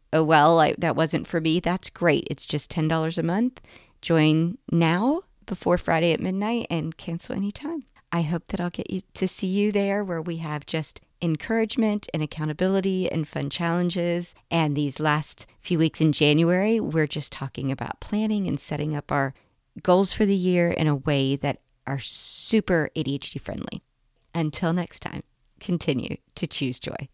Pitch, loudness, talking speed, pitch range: 165 Hz, -25 LUFS, 170 wpm, 150-185 Hz